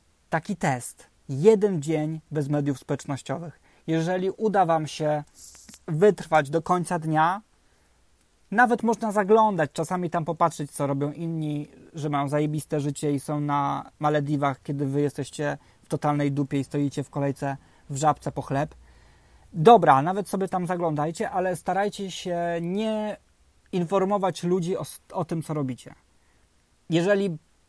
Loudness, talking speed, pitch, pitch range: -25 LUFS, 135 wpm, 155 Hz, 145-185 Hz